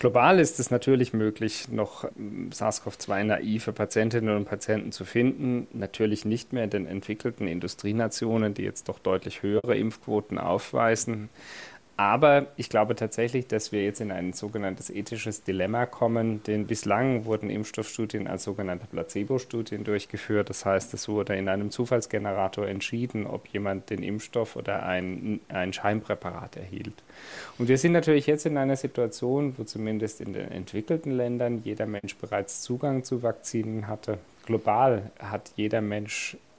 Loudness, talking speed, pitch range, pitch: -28 LUFS, 150 wpm, 100-120 Hz, 110 Hz